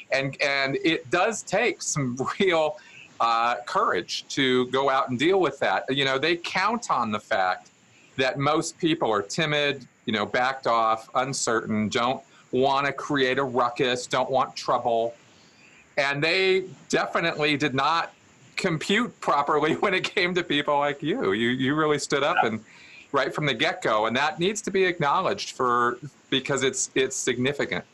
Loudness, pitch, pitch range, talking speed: -24 LUFS, 140 Hz, 130-160 Hz, 165 wpm